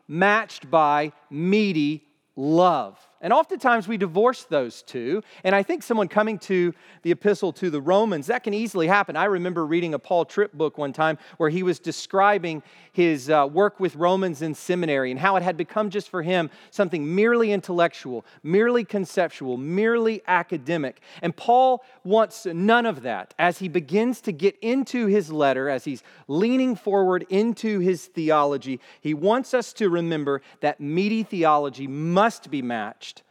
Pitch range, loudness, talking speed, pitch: 160-210 Hz, -23 LUFS, 165 wpm, 180 Hz